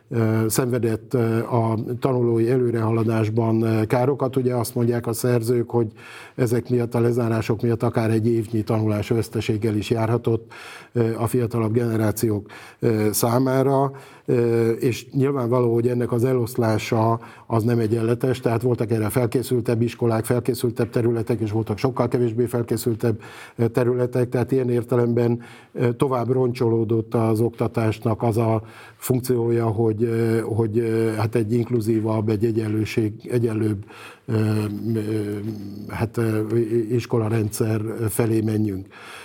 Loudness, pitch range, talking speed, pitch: -22 LUFS, 110-120 Hz, 110 wpm, 115 Hz